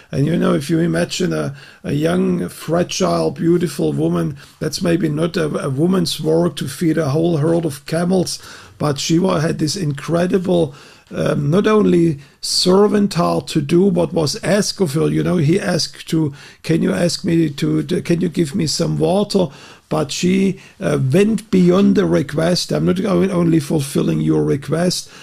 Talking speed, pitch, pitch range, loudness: 170 wpm, 170 Hz, 155-180 Hz, -17 LUFS